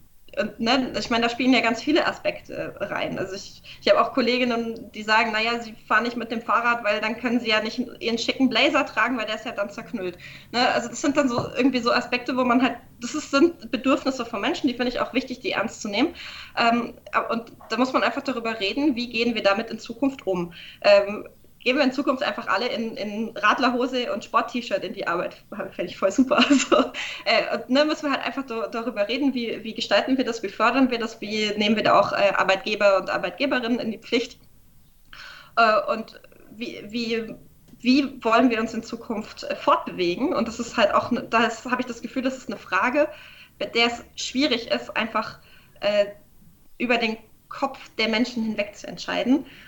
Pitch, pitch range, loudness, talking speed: 240 Hz, 220-270 Hz, -23 LUFS, 215 wpm